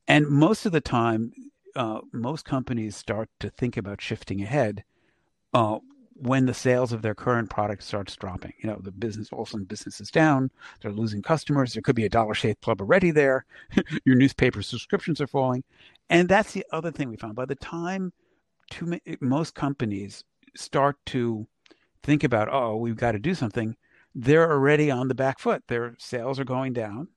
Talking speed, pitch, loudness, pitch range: 190 wpm, 125 Hz, -25 LUFS, 110-150 Hz